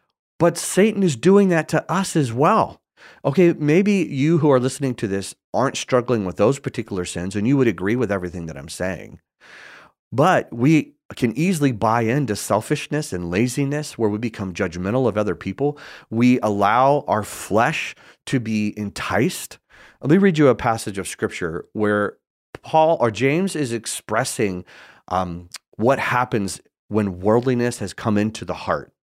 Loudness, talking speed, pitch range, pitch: -20 LUFS, 165 wpm, 100-150 Hz, 120 Hz